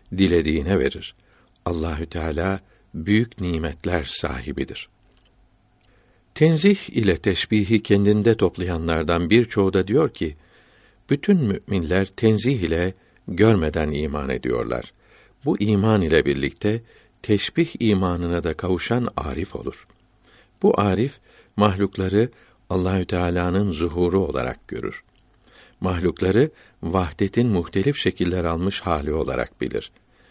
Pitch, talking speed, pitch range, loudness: 95 Hz, 95 wpm, 85-110 Hz, -22 LUFS